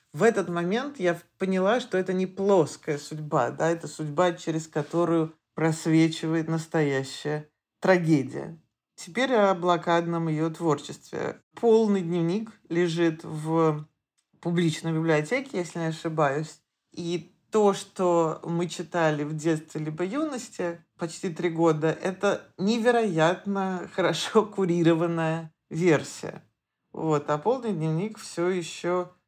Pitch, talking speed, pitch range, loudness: 170 Hz, 115 wpm, 160-185 Hz, -26 LUFS